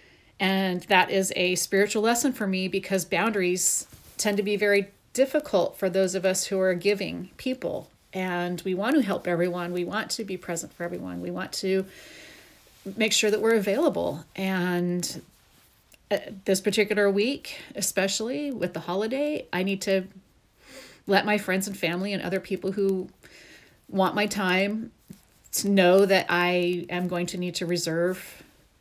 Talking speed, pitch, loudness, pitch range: 160 wpm, 190 Hz, -26 LUFS, 180-205 Hz